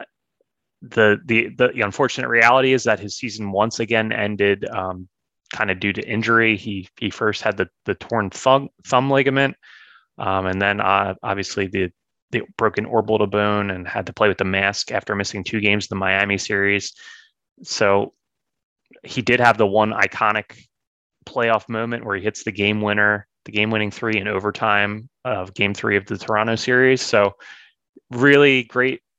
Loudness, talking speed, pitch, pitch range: -19 LUFS, 175 wpm, 105 Hz, 100-115 Hz